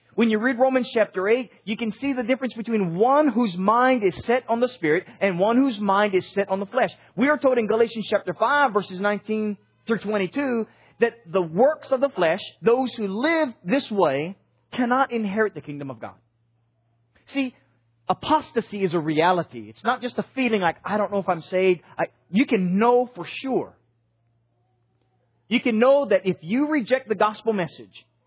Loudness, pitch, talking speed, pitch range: -23 LUFS, 210 Hz, 190 wpm, 175-245 Hz